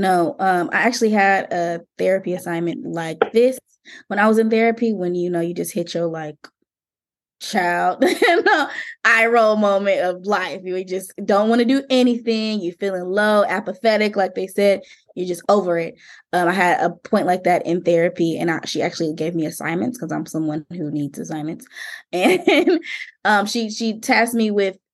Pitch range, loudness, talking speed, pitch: 175-225 Hz, -19 LUFS, 185 wpm, 190 Hz